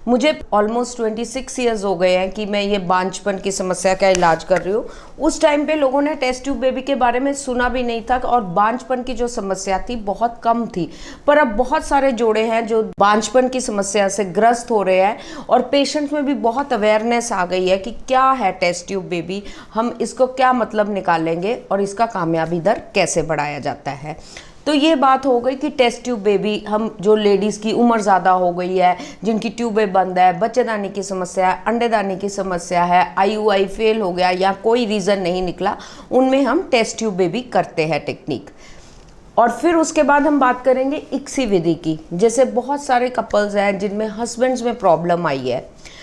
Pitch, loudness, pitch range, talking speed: 220 Hz, -18 LUFS, 190-250 Hz, 210 wpm